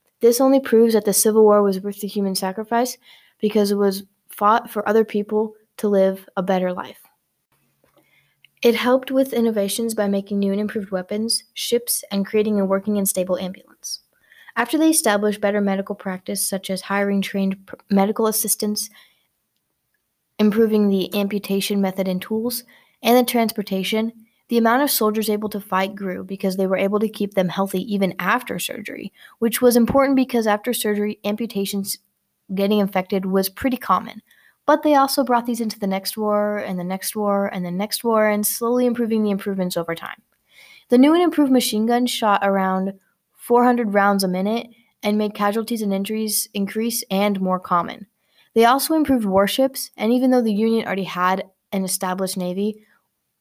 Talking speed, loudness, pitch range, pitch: 175 wpm, -20 LUFS, 195-230 Hz, 210 Hz